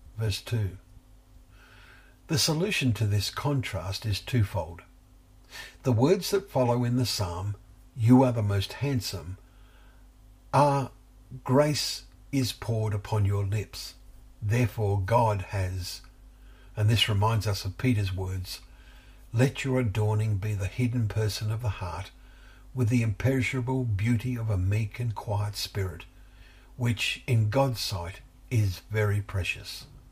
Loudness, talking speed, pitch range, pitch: -28 LUFS, 130 wpm, 90-120 Hz, 105 Hz